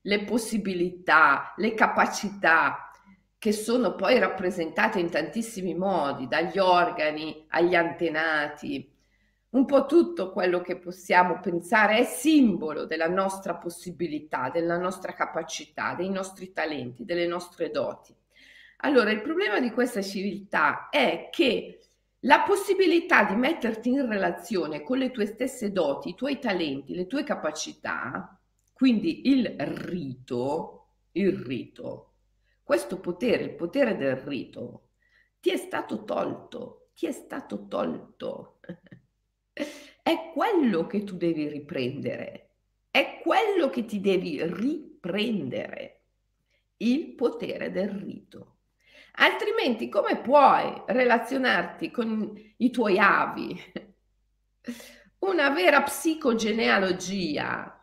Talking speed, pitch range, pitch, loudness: 110 wpm, 175-260 Hz, 205 Hz, -26 LUFS